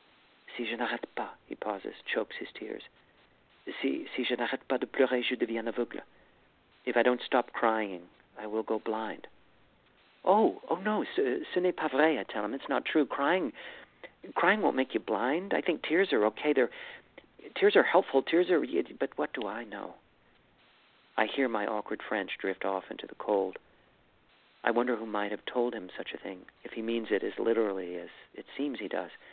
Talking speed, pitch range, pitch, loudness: 195 wpm, 110-150 Hz, 120 Hz, -31 LUFS